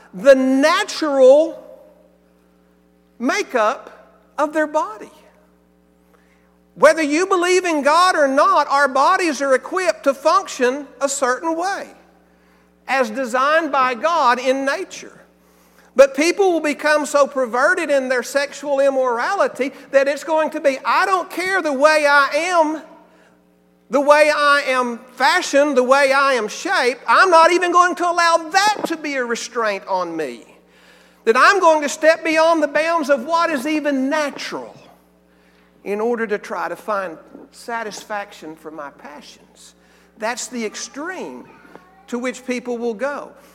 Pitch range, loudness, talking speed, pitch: 230-315 Hz, -17 LUFS, 145 wpm, 275 Hz